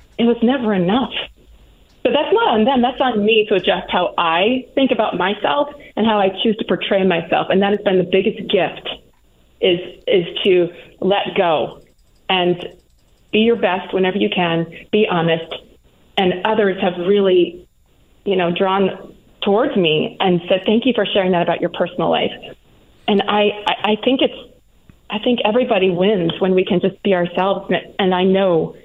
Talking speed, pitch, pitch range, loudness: 180 wpm, 195 Hz, 180-220 Hz, -17 LUFS